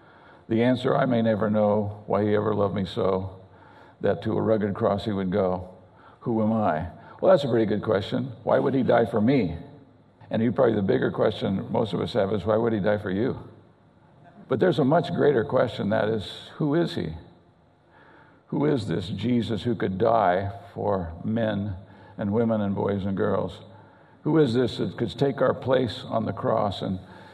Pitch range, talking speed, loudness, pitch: 95-115 Hz, 200 wpm, -25 LUFS, 105 Hz